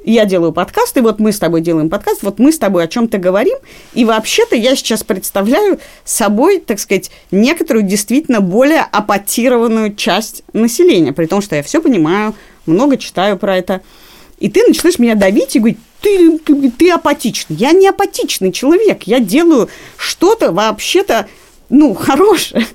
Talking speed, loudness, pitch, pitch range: 165 wpm, -12 LUFS, 235 Hz, 200-310 Hz